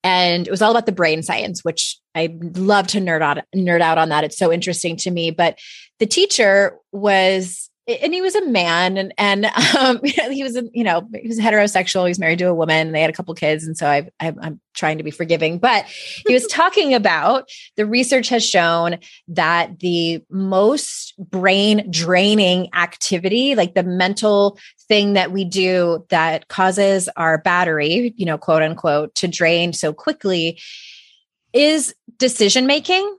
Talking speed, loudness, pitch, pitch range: 180 wpm, -17 LUFS, 185 Hz, 165-215 Hz